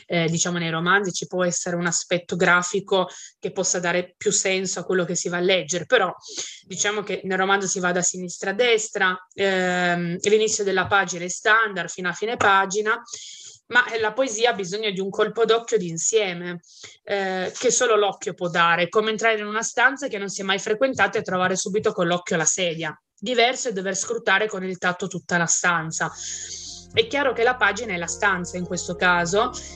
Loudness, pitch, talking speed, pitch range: -22 LUFS, 190 Hz, 200 wpm, 175-215 Hz